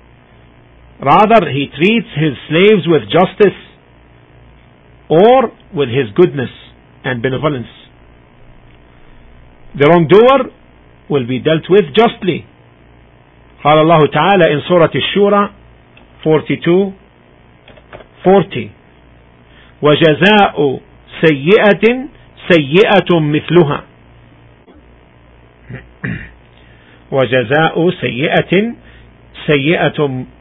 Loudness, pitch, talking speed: -12 LUFS, 130 Hz, 70 wpm